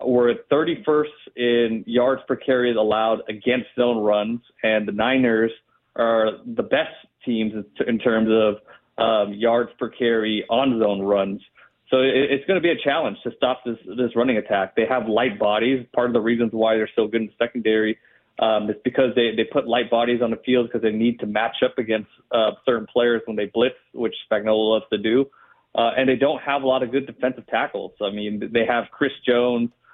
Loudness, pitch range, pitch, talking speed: -21 LUFS, 110-125 Hz, 120 Hz, 200 wpm